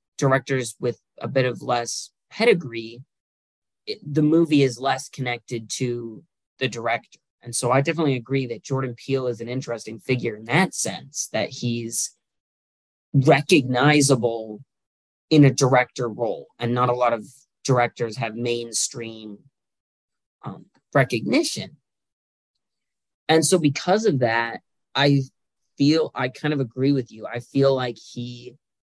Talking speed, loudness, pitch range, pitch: 135 wpm, -22 LUFS, 115-140 Hz, 125 Hz